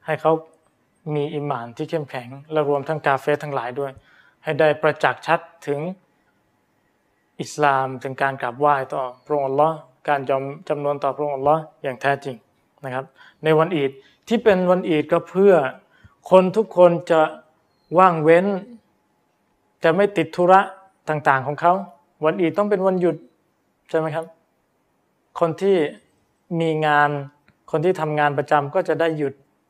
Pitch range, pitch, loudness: 145-170 Hz, 155 Hz, -20 LUFS